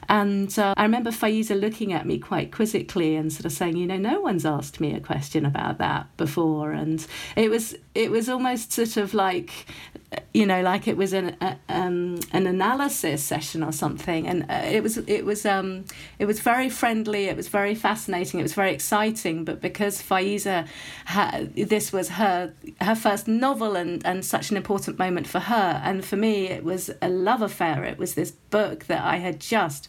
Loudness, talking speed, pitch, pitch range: -25 LUFS, 200 wpm, 190 Hz, 170-210 Hz